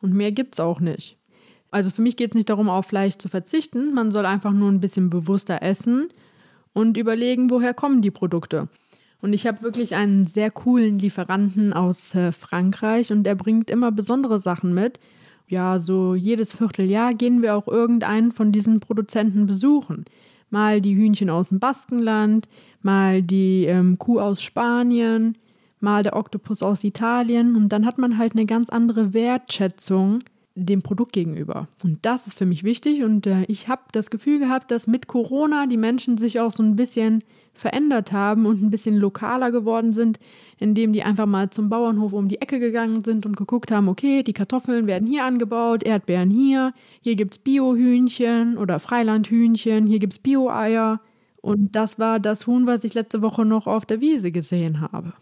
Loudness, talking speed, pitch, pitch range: -21 LUFS, 180 wpm, 220 Hz, 200-235 Hz